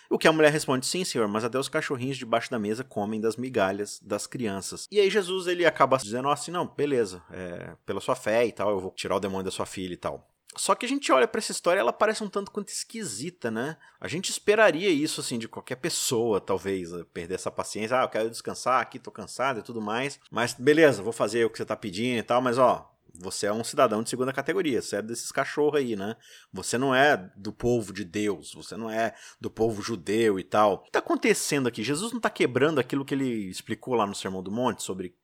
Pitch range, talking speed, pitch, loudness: 110-170 Hz, 240 wpm, 125 Hz, -27 LUFS